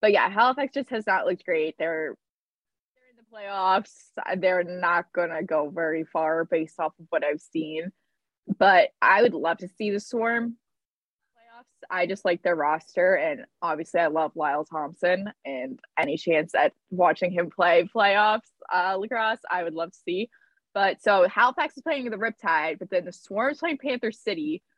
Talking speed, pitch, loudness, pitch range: 185 wpm, 190 Hz, -25 LUFS, 165-230 Hz